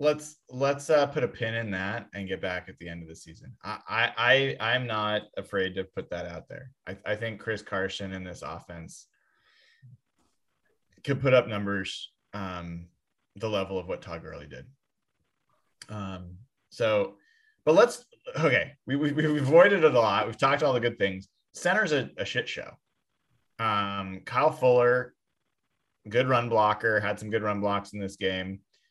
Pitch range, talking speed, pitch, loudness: 95-130 Hz, 175 wpm, 105 Hz, -27 LUFS